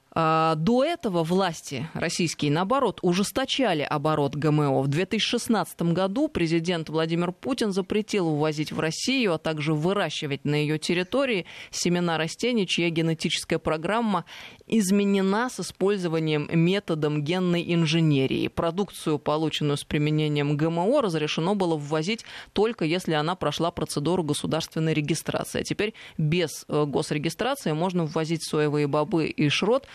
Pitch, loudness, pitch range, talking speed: 165 Hz, -25 LUFS, 155-195 Hz, 120 wpm